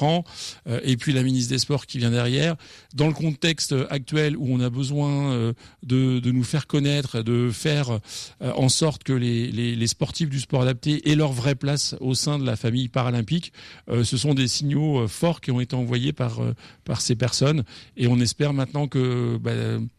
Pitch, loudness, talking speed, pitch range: 130 Hz, -23 LUFS, 190 wpm, 120-145 Hz